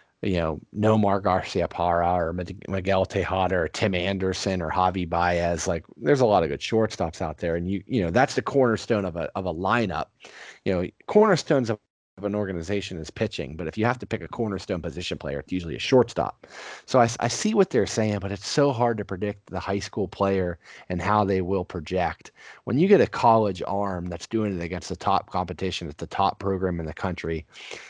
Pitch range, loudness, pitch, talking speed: 90-105 Hz, -25 LUFS, 95 Hz, 215 wpm